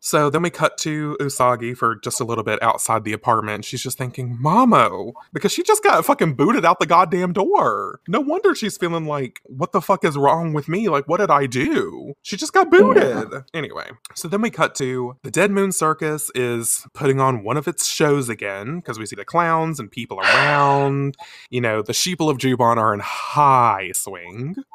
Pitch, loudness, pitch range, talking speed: 145 Hz, -19 LUFS, 125-180 Hz, 205 wpm